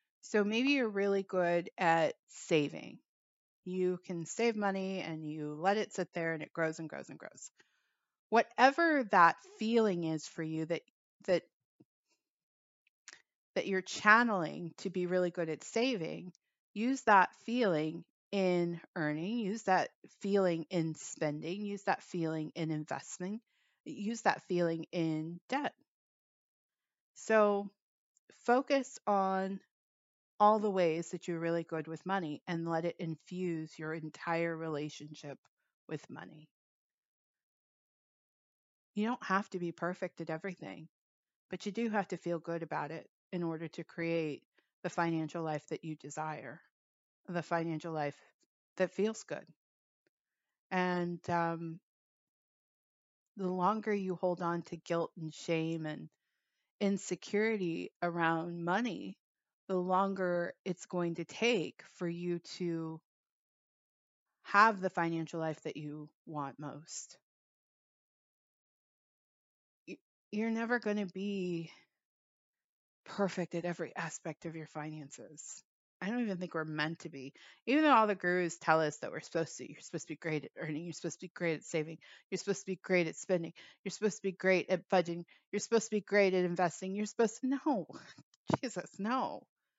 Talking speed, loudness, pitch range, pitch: 150 wpm, -35 LUFS, 165-200 Hz, 175 Hz